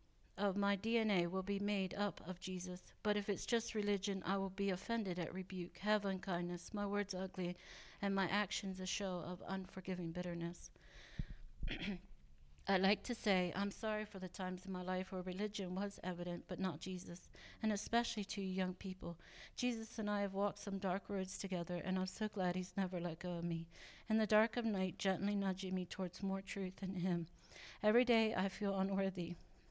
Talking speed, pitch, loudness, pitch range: 190 wpm, 190 Hz, -41 LUFS, 180-205 Hz